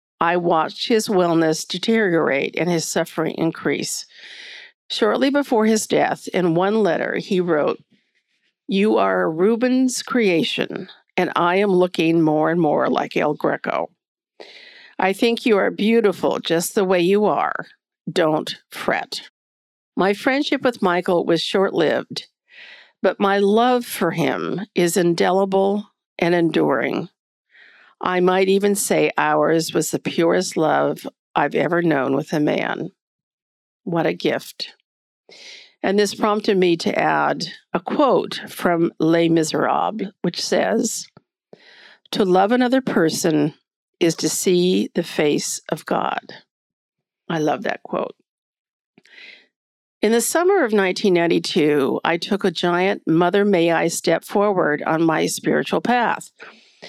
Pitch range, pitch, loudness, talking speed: 165-210 Hz, 185 Hz, -19 LUFS, 130 wpm